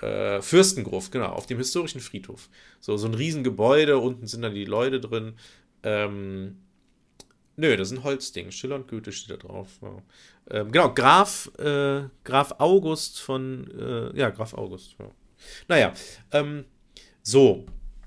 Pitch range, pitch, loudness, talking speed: 100-140 Hz, 125 Hz, -24 LUFS, 145 wpm